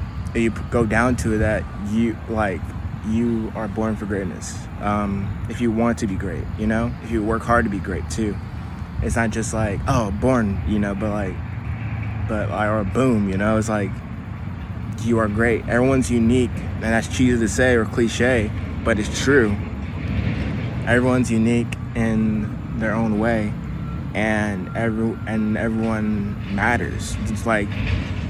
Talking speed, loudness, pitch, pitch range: 165 wpm, -22 LUFS, 110 Hz, 100-115 Hz